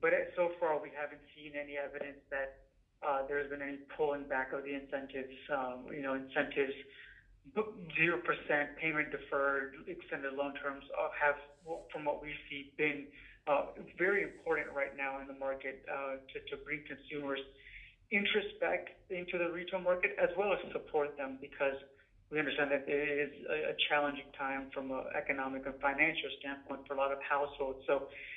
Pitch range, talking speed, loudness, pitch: 135-150 Hz, 165 wpm, -37 LUFS, 140 Hz